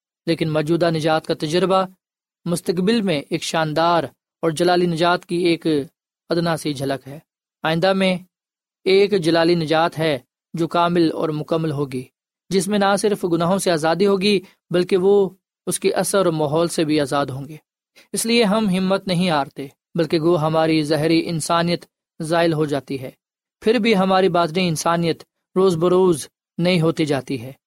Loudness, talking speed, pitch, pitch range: -19 LUFS, 165 wpm, 170 Hz, 160-190 Hz